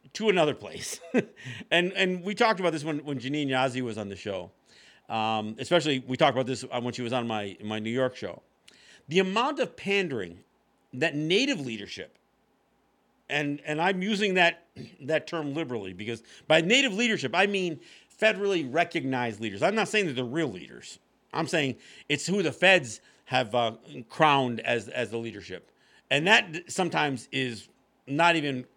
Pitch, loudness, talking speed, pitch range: 145 Hz, -27 LUFS, 170 wpm, 125-180 Hz